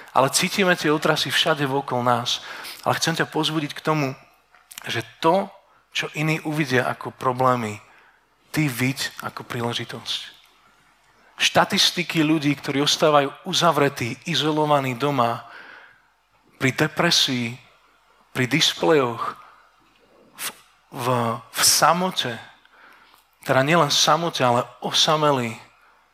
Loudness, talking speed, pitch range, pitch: -21 LUFS, 105 wpm, 130-160 Hz, 145 Hz